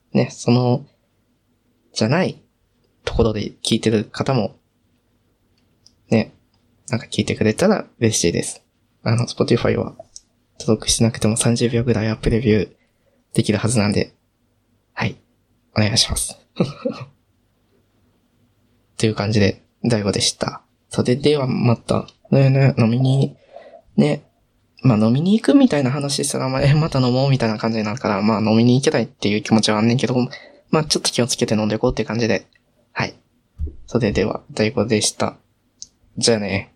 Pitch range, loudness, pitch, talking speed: 110-125 Hz, -19 LUFS, 115 Hz, 315 characters per minute